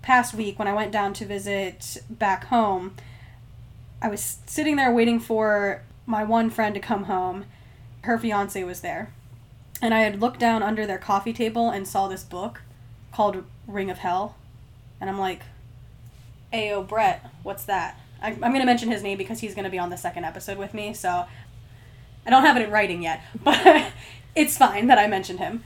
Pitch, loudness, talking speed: 200 Hz, -23 LUFS, 195 wpm